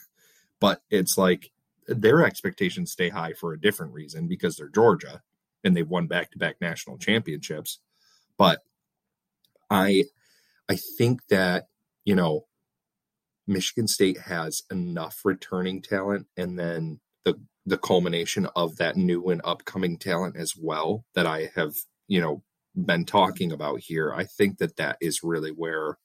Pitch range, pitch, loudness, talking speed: 85-120 Hz, 90 Hz, -26 LUFS, 145 wpm